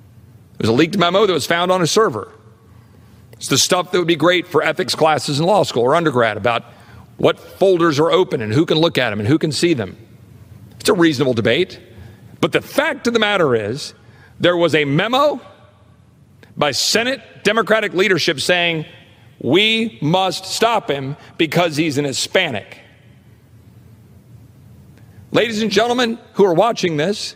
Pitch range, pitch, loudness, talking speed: 115-185 Hz, 155 Hz, -16 LUFS, 170 wpm